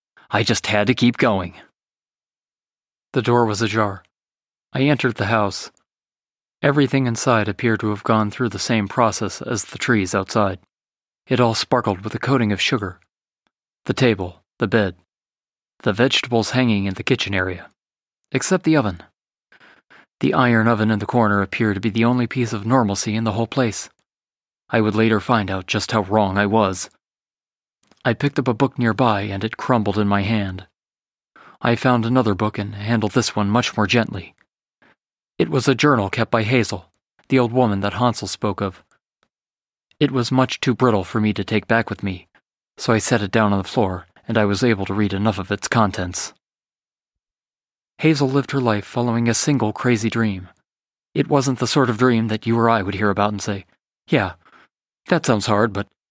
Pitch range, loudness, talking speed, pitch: 100-125 Hz, -20 LUFS, 185 wpm, 110 Hz